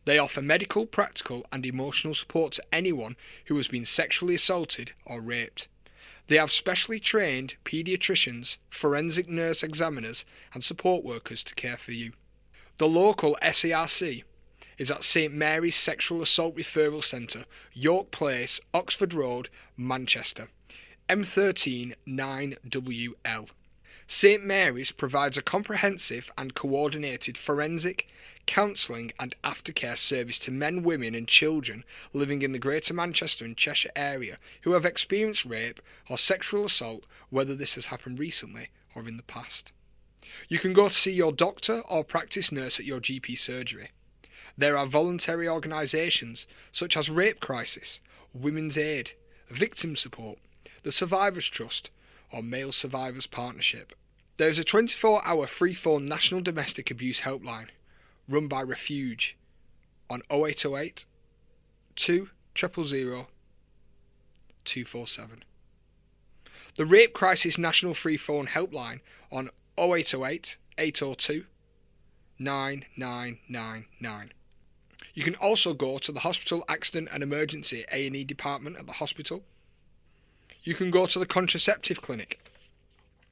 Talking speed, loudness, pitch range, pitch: 130 wpm, -27 LUFS, 125-170 Hz, 145 Hz